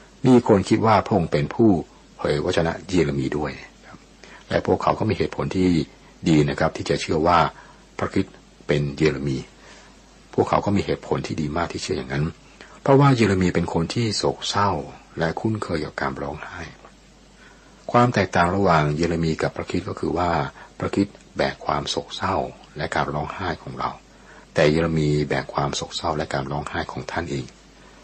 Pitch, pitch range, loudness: 85 Hz, 75-100 Hz, -22 LUFS